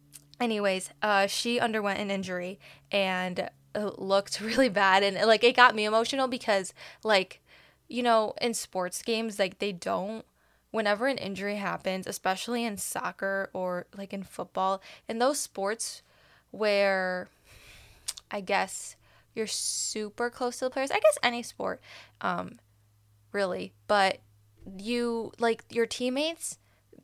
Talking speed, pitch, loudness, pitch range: 135 wpm, 200 Hz, -29 LUFS, 185-230 Hz